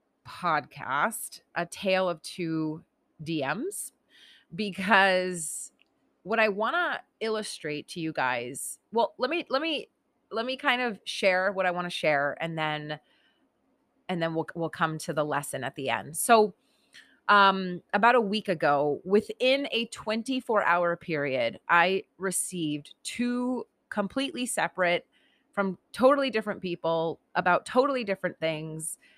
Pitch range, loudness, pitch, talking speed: 165-230 Hz, -28 LUFS, 190 Hz, 135 wpm